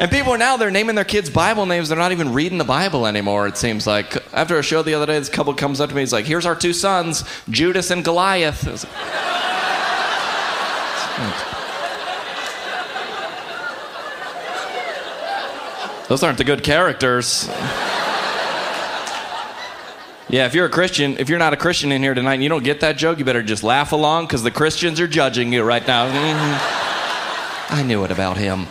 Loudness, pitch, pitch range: -19 LUFS, 150 Hz, 130-170 Hz